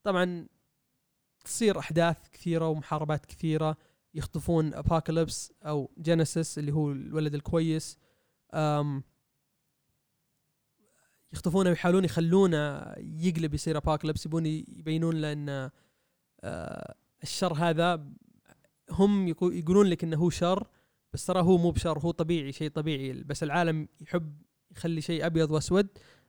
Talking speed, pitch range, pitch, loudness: 110 wpm, 155-175 Hz, 165 Hz, -29 LUFS